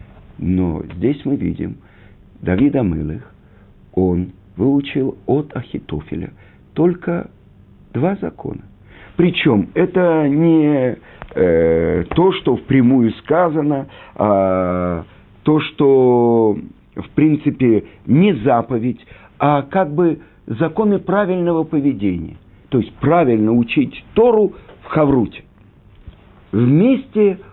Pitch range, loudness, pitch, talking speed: 100-165 Hz, -16 LUFS, 135 Hz, 90 wpm